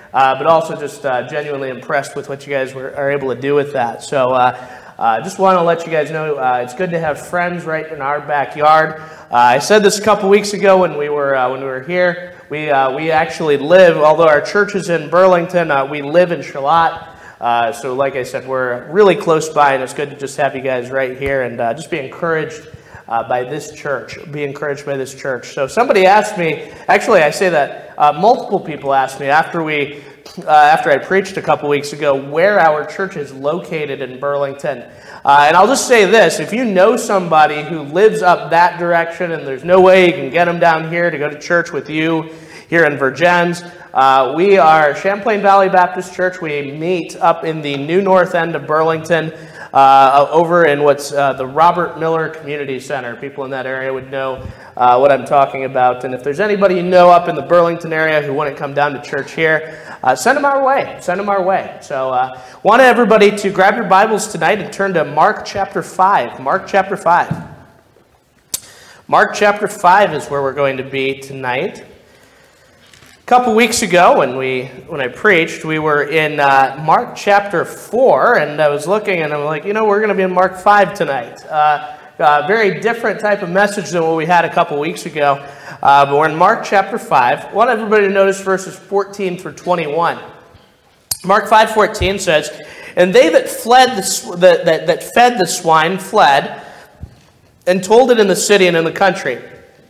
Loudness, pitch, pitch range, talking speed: -14 LUFS, 160 Hz, 140-190 Hz, 215 wpm